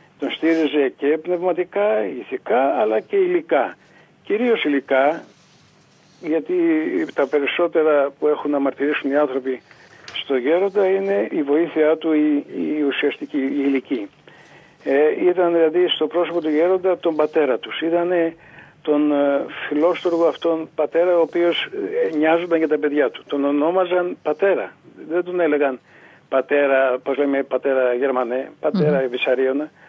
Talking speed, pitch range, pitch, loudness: 125 wpm, 140-175 Hz, 155 Hz, -20 LUFS